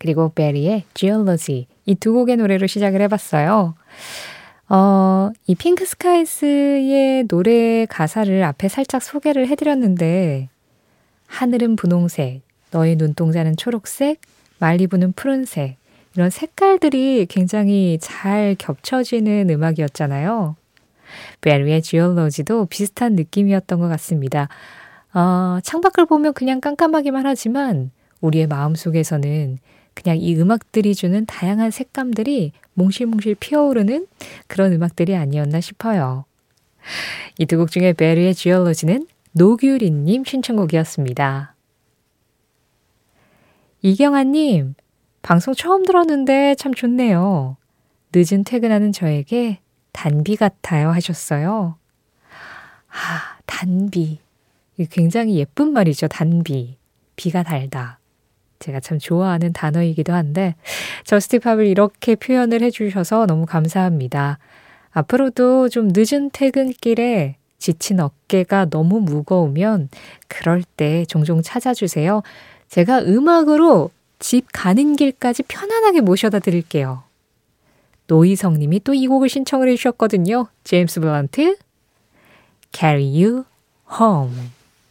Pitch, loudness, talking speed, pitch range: 190 Hz, -17 LUFS, 275 characters per minute, 160-240 Hz